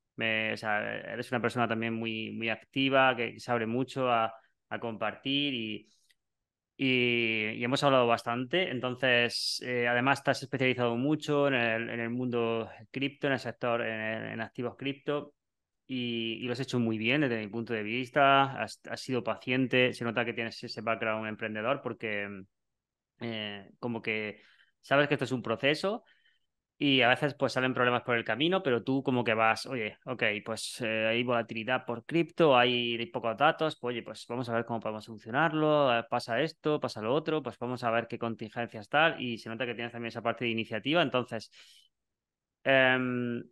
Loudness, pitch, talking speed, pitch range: -30 LUFS, 120 Hz, 190 wpm, 115-130 Hz